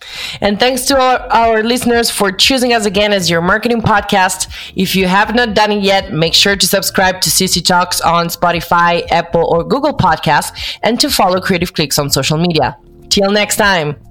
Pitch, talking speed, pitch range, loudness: 195 Hz, 190 wpm, 170-220 Hz, -12 LUFS